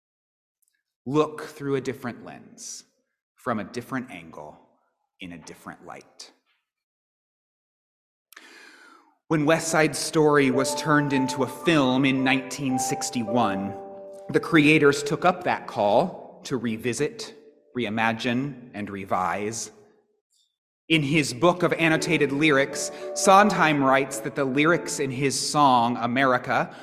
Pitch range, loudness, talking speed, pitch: 130-175 Hz, -23 LUFS, 110 wpm, 145 Hz